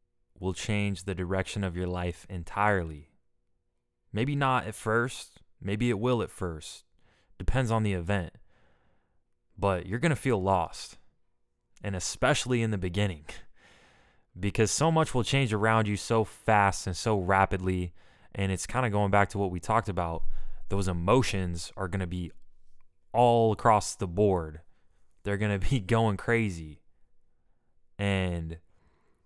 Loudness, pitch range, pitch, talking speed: -29 LUFS, 90-115 Hz, 100 Hz, 150 wpm